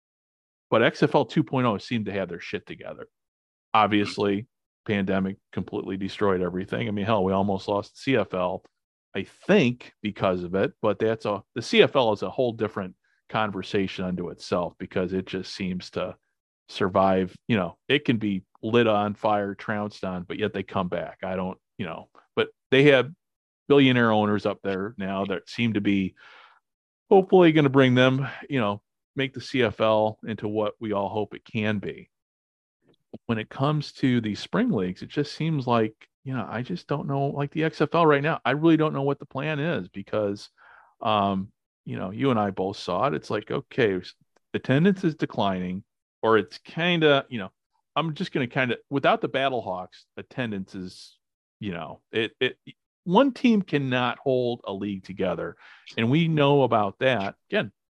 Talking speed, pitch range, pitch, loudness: 180 wpm, 100-135 Hz, 110 Hz, -25 LUFS